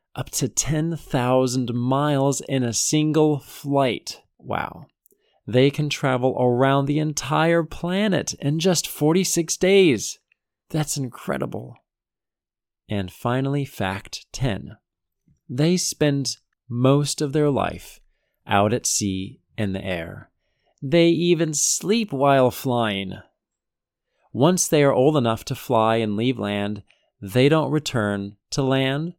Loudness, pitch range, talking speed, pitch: -21 LUFS, 115-155 Hz, 120 wpm, 135 Hz